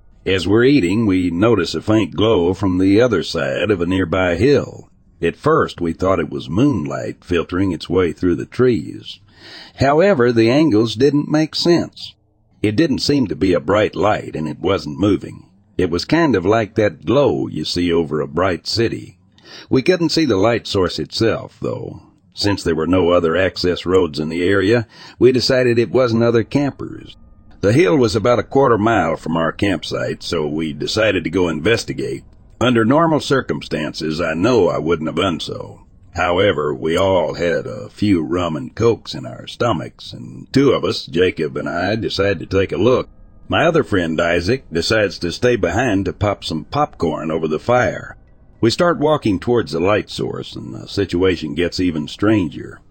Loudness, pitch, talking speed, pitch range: -17 LUFS, 100 Hz, 185 wpm, 85-120 Hz